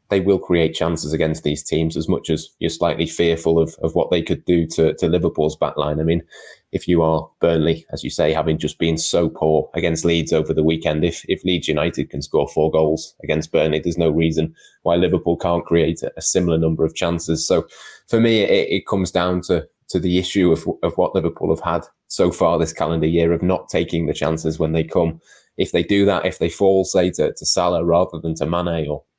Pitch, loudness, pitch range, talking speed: 80 Hz, -19 LUFS, 80-85 Hz, 230 wpm